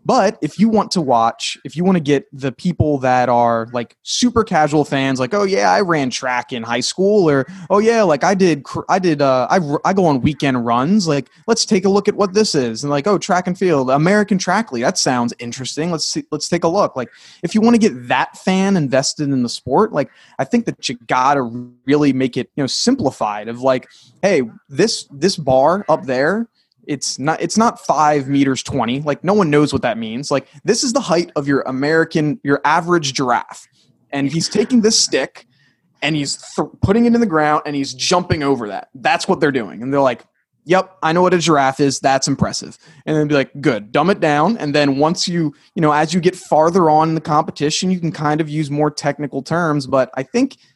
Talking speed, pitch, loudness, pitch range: 230 wpm, 150 Hz, -16 LUFS, 135-185 Hz